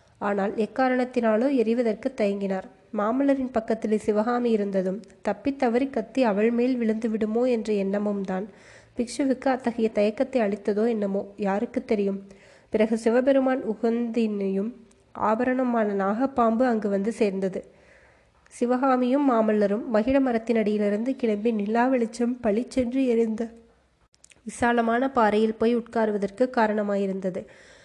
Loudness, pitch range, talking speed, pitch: -25 LUFS, 210-245 Hz, 100 wpm, 225 Hz